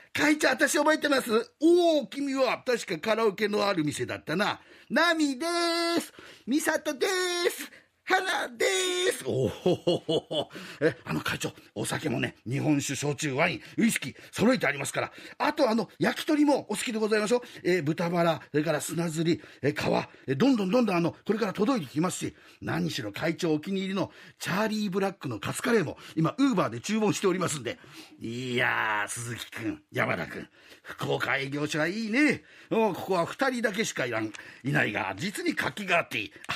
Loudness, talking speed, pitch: -28 LUFS, 365 characters per minute, 205 Hz